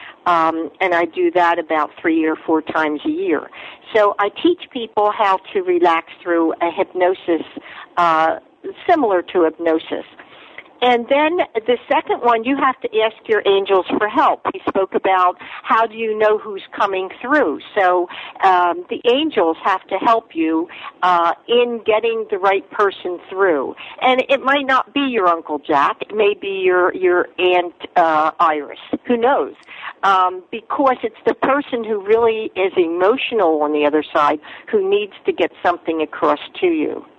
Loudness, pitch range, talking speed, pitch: -17 LUFS, 175-265 Hz, 165 wpm, 205 Hz